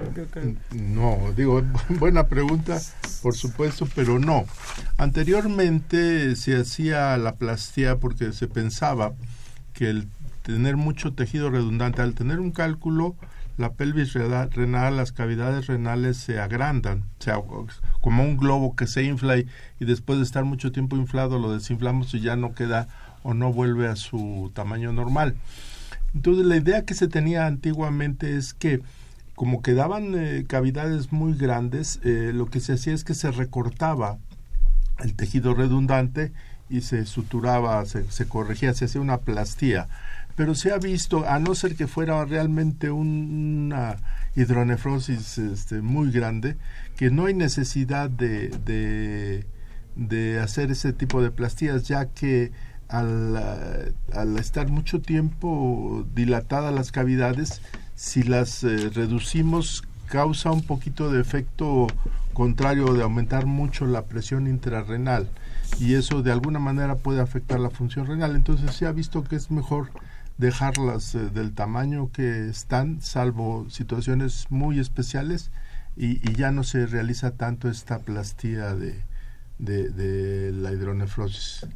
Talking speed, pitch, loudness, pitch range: 140 wpm, 125 Hz, -25 LUFS, 115-145 Hz